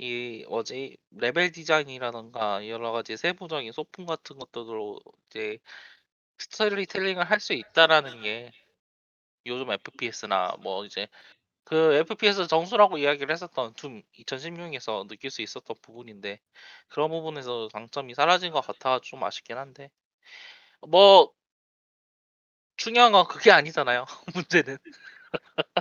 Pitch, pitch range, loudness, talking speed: 150 Hz, 120-185 Hz, -25 LUFS, 265 characters per minute